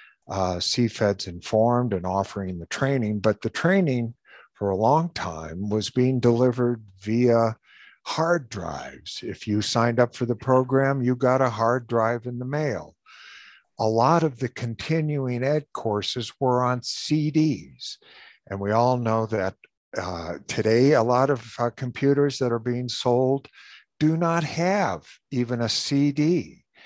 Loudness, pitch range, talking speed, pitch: -24 LUFS, 110-135 Hz, 150 wpm, 120 Hz